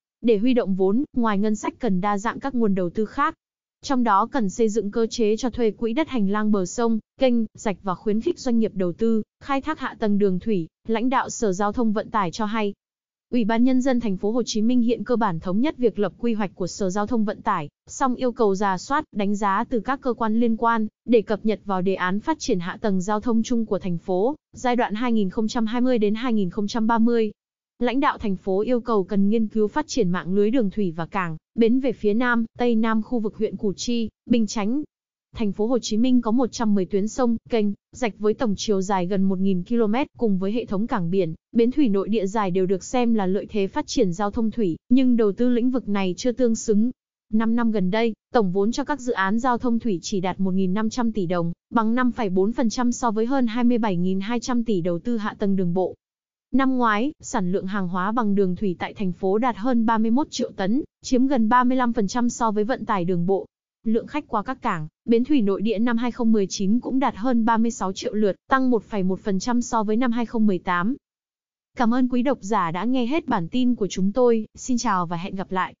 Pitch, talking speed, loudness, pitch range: 225 Hz, 230 wpm, -23 LUFS, 200-245 Hz